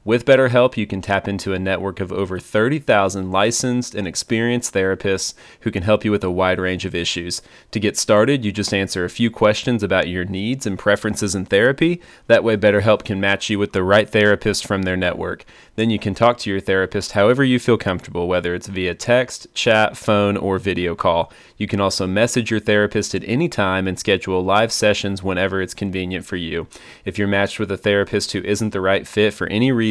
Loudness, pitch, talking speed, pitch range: -19 LUFS, 100 Hz, 215 wpm, 95-110 Hz